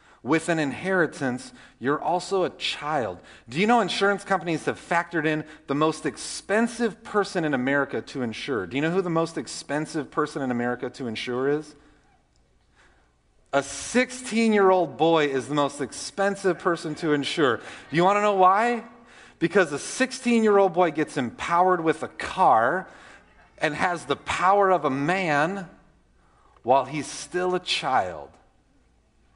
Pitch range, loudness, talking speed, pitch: 140-190 Hz, -24 LUFS, 150 wpm, 165 Hz